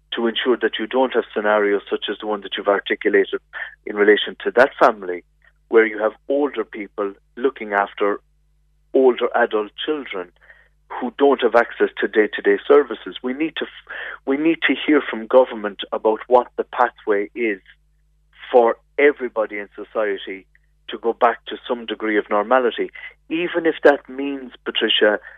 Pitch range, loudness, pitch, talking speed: 110-165 Hz, -20 LUFS, 130 Hz, 160 wpm